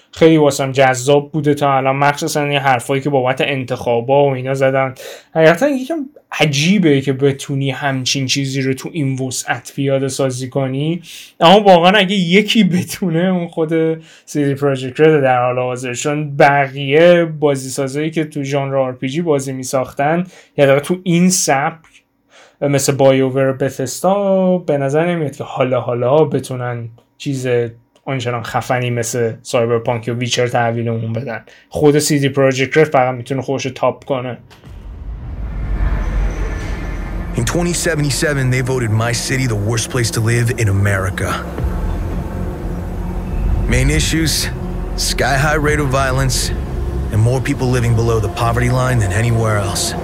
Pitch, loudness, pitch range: 135 Hz, -16 LUFS, 120-150 Hz